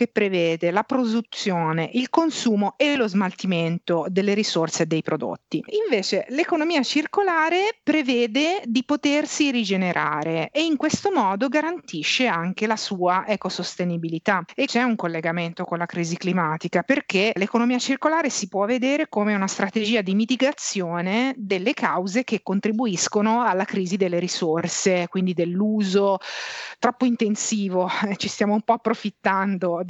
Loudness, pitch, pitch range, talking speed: -22 LUFS, 210 Hz, 180-255 Hz, 135 wpm